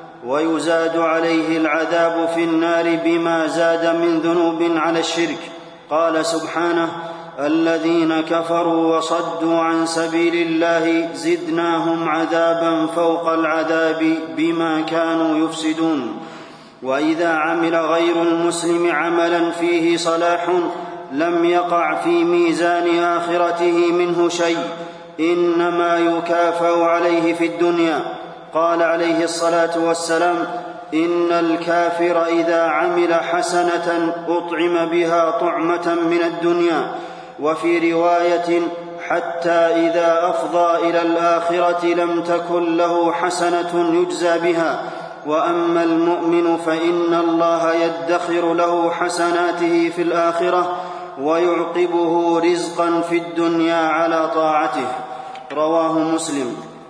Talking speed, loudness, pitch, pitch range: 95 wpm, -18 LUFS, 170 Hz, 165-170 Hz